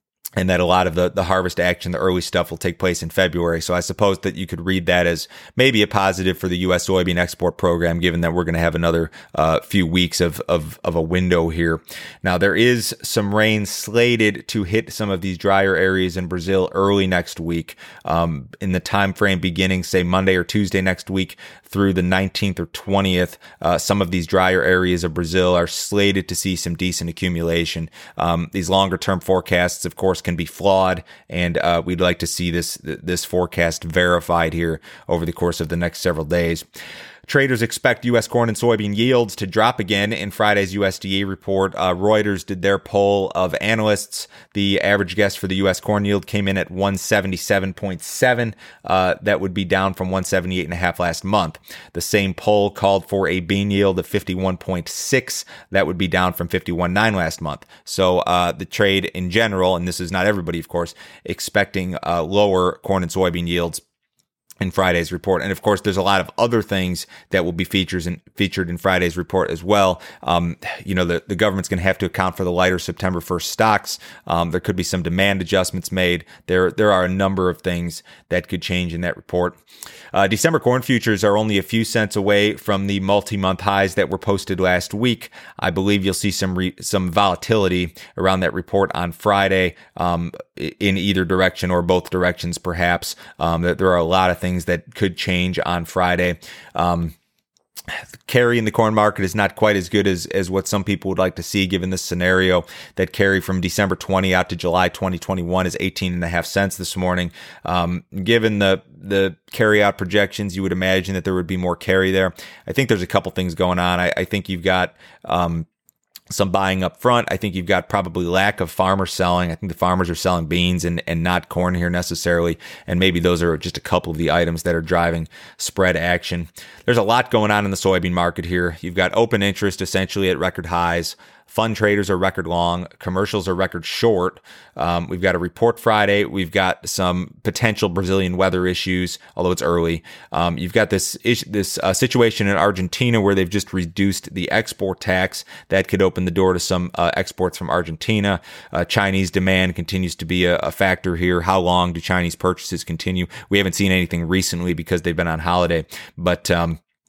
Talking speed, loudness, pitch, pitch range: 205 wpm, -19 LUFS, 95 Hz, 90-100 Hz